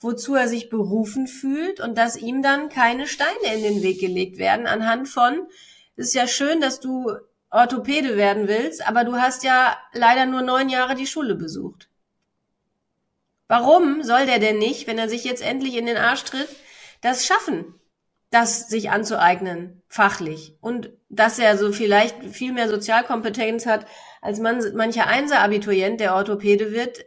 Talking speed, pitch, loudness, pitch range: 165 wpm, 235 Hz, -20 LUFS, 215-260 Hz